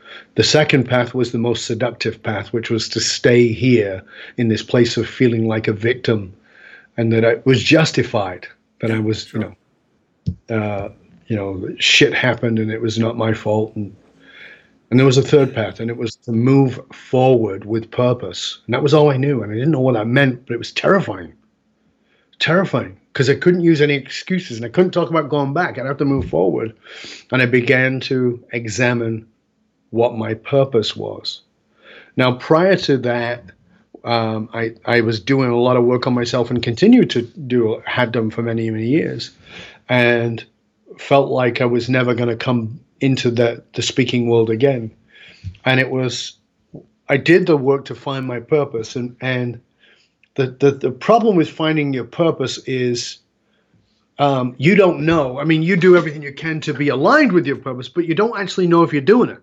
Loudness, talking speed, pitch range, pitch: -17 LUFS, 195 wpm, 115-140 Hz, 125 Hz